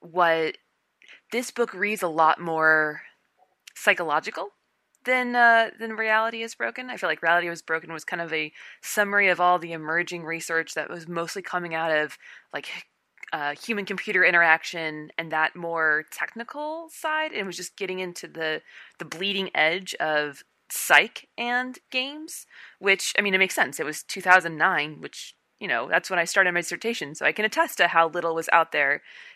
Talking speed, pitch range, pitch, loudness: 180 wpm, 160-215 Hz, 175 Hz, -24 LUFS